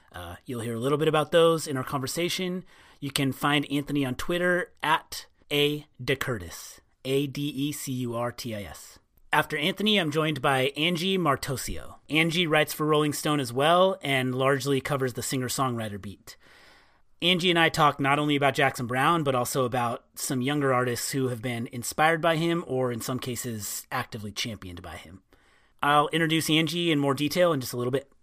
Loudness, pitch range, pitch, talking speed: -26 LUFS, 125-155 Hz, 140 Hz, 170 wpm